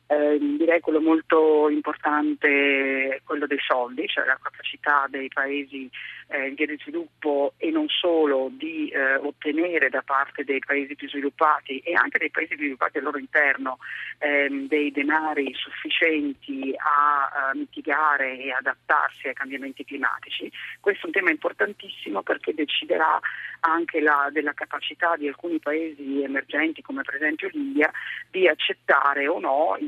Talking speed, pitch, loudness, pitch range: 150 wpm, 145 Hz, -24 LUFS, 140-160 Hz